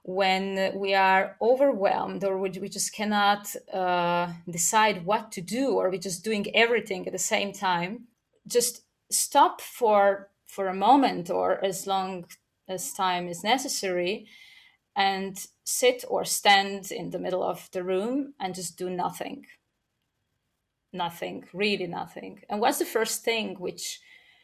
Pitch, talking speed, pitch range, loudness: 195 Hz, 140 wpm, 185-225 Hz, -26 LUFS